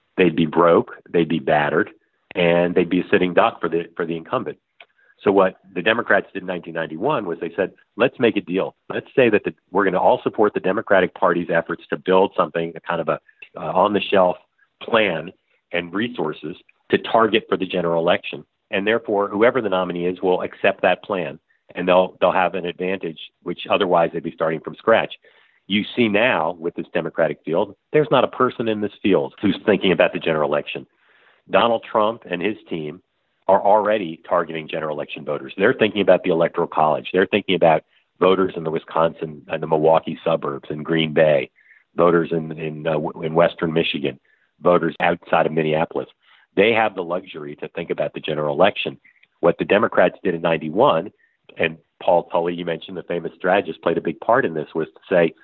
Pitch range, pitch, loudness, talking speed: 80-95 Hz, 85 Hz, -20 LUFS, 200 wpm